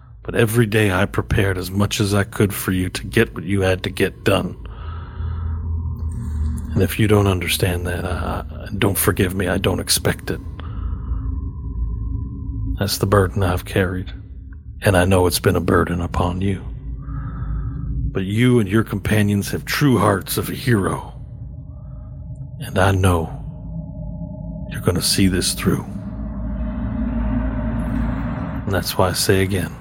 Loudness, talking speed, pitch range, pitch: -20 LUFS, 150 wpm, 90-105 Hz, 95 Hz